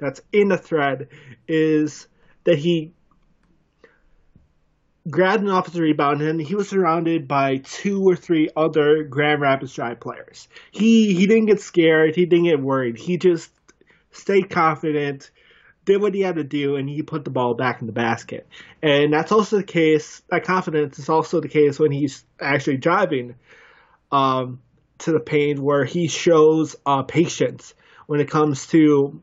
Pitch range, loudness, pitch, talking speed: 140-170 Hz, -20 LUFS, 155 Hz, 165 wpm